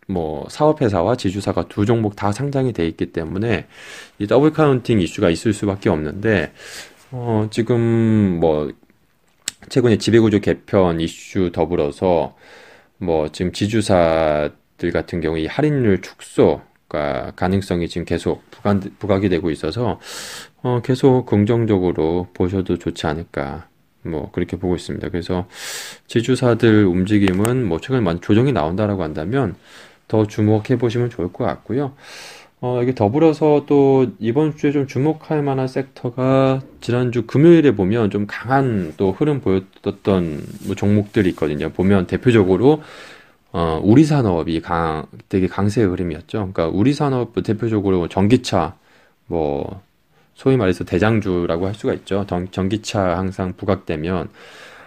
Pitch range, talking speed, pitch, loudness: 90-125 Hz, 295 characters per minute, 100 Hz, -19 LUFS